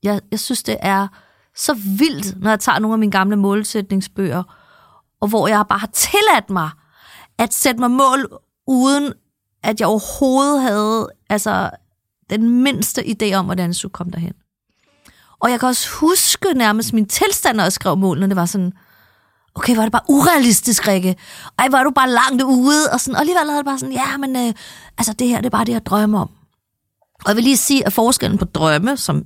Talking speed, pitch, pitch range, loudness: 205 wpm, 220 Hz, 195-265 Hz, -16 LUFS